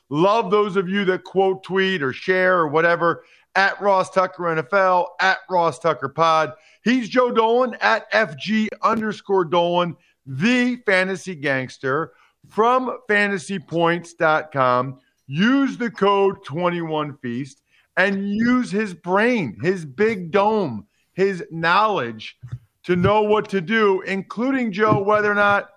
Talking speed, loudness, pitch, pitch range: 125 wpm, -20 LUFS, 190 Hz, 165-210 Hz